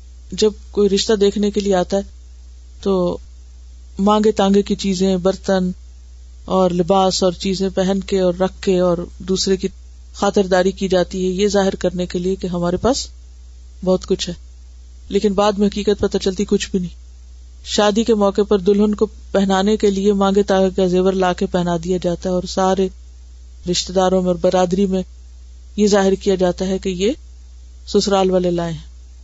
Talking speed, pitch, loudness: 180 wpm, 190 Hz, -17 LUFS